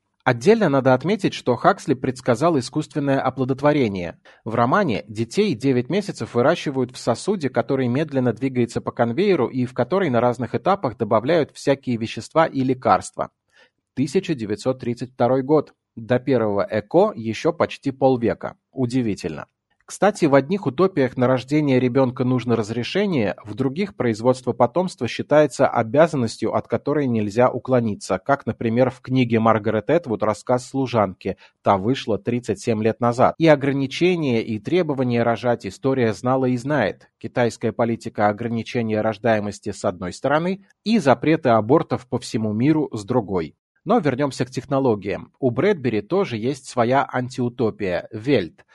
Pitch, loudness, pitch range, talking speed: 125 Hz, -21 LUFS, 115-140 Hz, 135 wpm